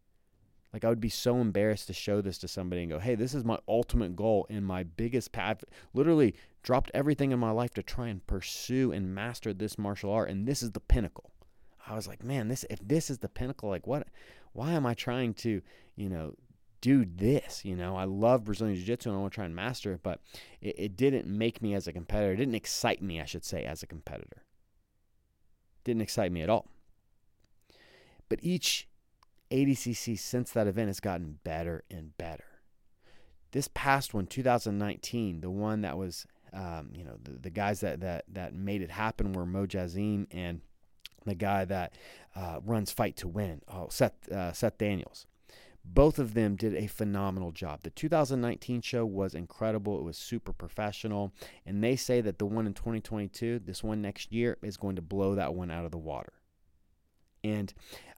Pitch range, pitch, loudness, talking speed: 95-115 Hz, 105 Hz, -33 LUFS, 200 wpm